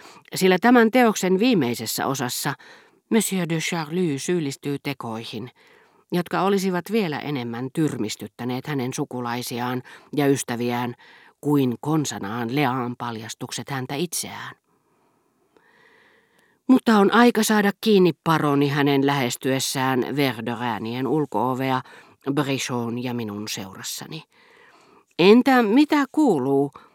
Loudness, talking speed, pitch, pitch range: -22 LUFS, 95 wpm, 140 Hz, 125-185 Hz